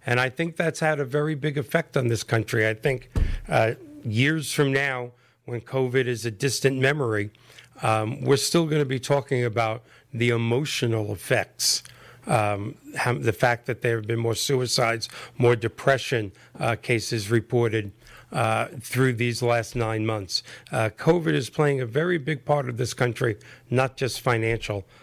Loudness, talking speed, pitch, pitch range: -25 LUFS, 170 wpm, 125 Hz, 115-140 Hz